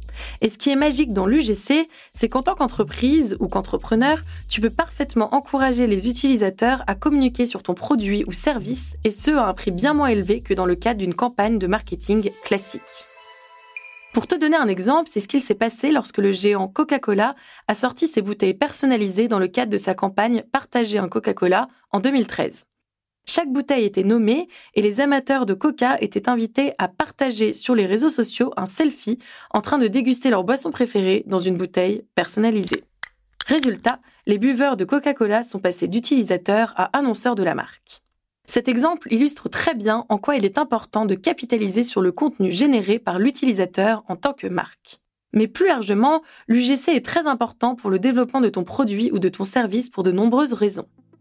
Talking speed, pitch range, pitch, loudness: 185 wpm, 205-275 Hz, 235 Hz, -20 LUFS